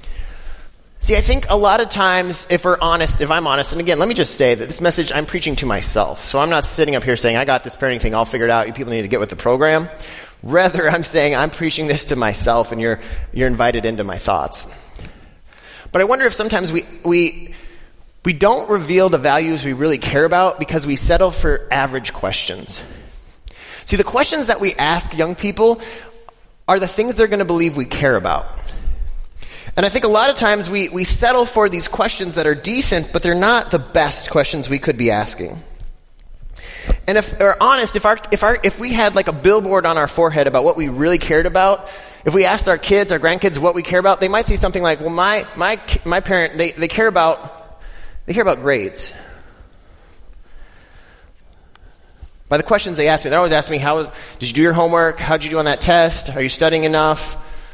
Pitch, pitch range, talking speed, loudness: 165 Hz, 130-190 Hz, 215 wpm, -16 LUFS